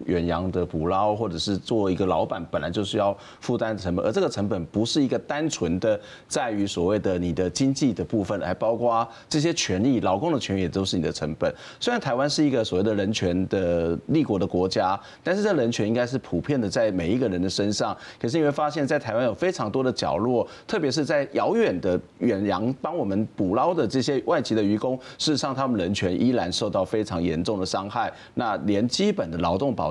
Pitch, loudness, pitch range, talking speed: 105 Hz, -25 LUFS, 90-125 Hz, 335 characters per minute